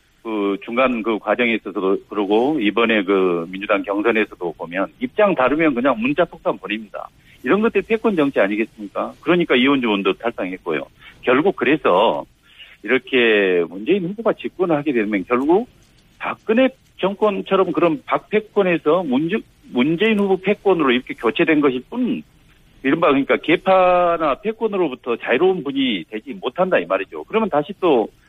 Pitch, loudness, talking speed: 150 Hz, -19 LUFS, 350 characters per minute